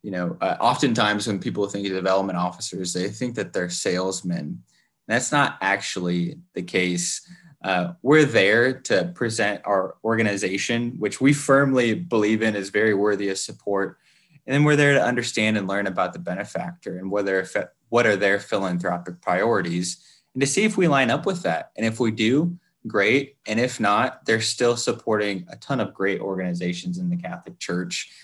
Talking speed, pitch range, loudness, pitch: 180 wpm, 95-130 Hz, -23 LUFS, 105 Hz